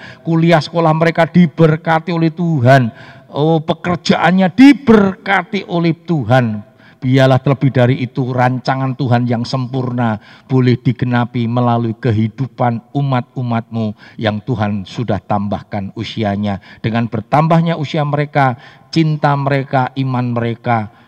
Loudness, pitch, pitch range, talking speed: -15 LUFS, 130 Hz, 120-160 Hz, 105 wpm